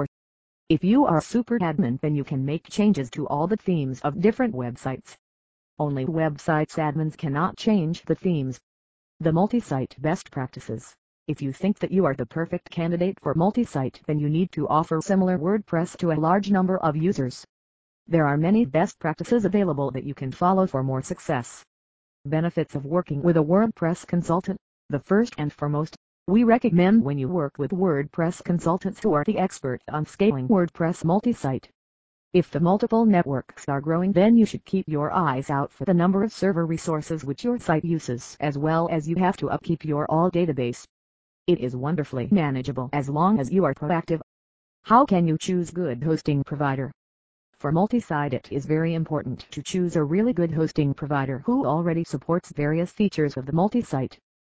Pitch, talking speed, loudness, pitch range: 160 Hz, 180 wpm, -24 LUFS, 140-185 Hz